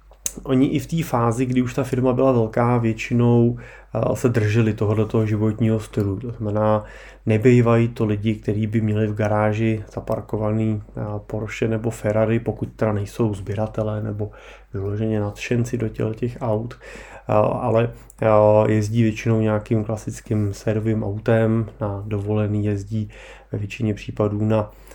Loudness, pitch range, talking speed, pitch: -21 LUFS, 105-115 Hz, 130 wpm, 110 Hz